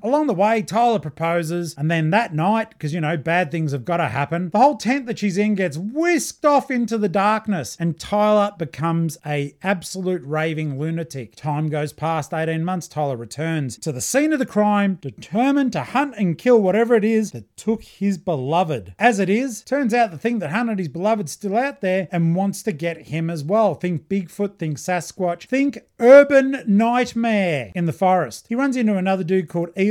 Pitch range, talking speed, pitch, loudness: 165-225 Hz, 205 wpm, 190 Hz, -20 LUFS